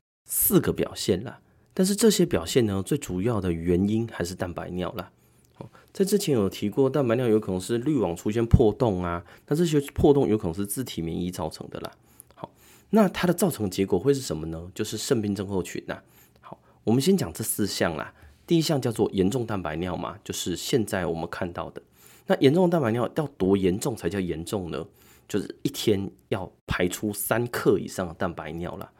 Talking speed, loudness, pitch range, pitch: 300 characters per minute, -26 LUFS, 90-140 Hz, 105 Hz